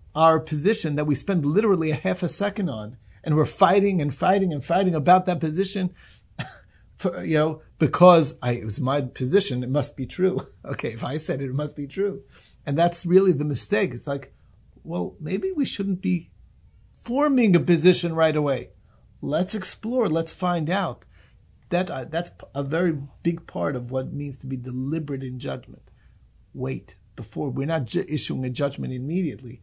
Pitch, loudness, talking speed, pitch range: 155 Hz, -23 LUFS, 180 wpm, 130-180 Hz